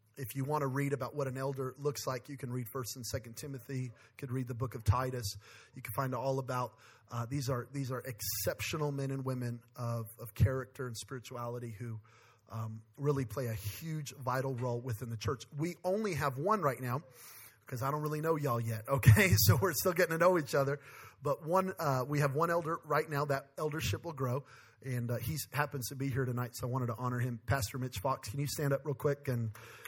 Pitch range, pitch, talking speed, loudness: 120-145 Hz, 130 Hz, 225 wpm, -35 LUFS